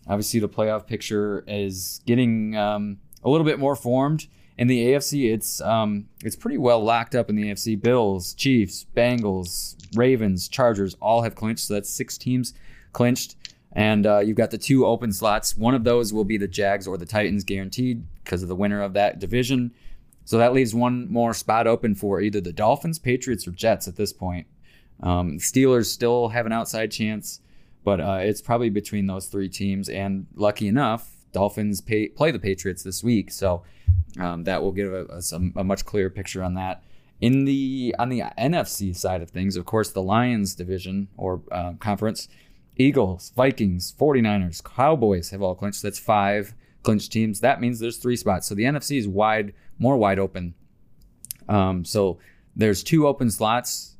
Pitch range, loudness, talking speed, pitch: 95-120 Hz, -23 LUFS, 185 wpm, 105 Hz